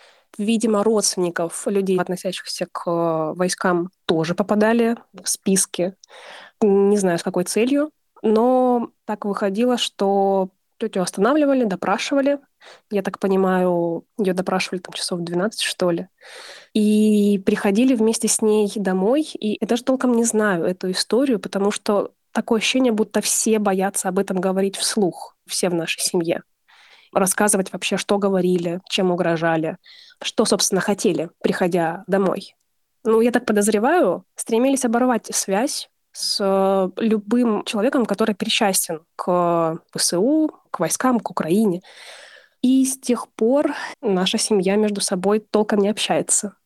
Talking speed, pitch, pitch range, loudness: 130 wpm, 205 Hz, 185-225 Hz, -20 LUFS